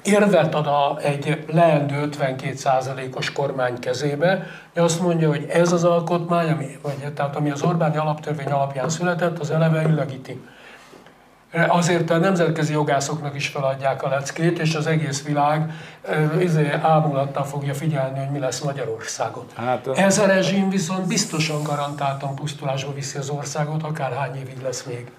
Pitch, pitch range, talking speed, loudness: 150 Hz, 140-165 Hz, 145 wpm, -22 LUFS